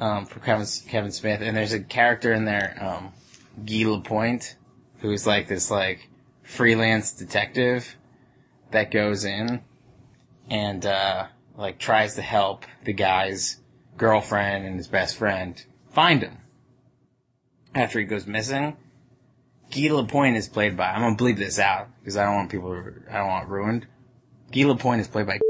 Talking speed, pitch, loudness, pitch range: 160 wpm, 110 Hz, -24 LUFS, 100-125 Hz